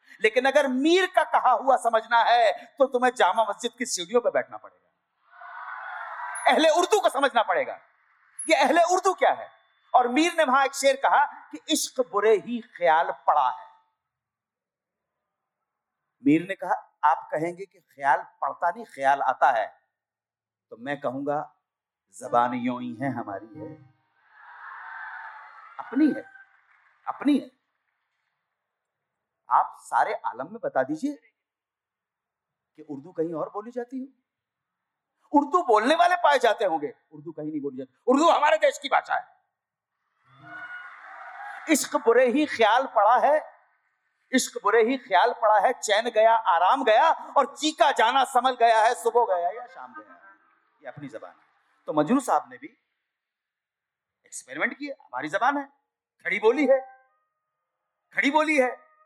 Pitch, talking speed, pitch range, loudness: 260 Hz, 145 wpm, 210-310 Hz, -23 LUFS